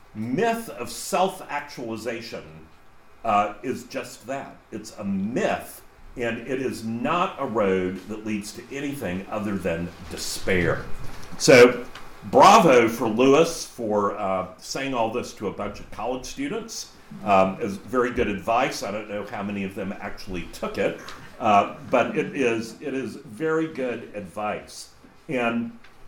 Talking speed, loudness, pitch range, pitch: 140 wpm, -24 LUFS, 100-130 Hz, 115 Hz